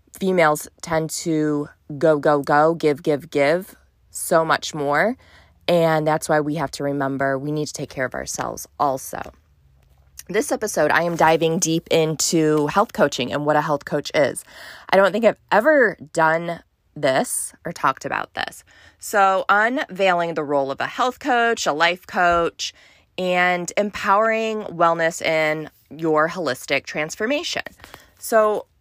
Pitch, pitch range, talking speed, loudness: 160 Hz, 150-185 Hz, 150 wpm, -20 LUFS